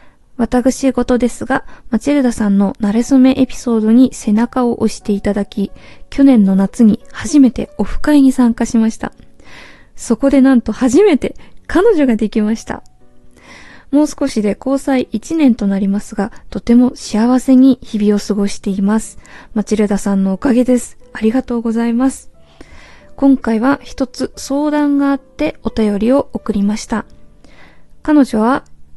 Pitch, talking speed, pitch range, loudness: 235 Hz, 295 characters per minute, 215-265 Hz, -14 LUFS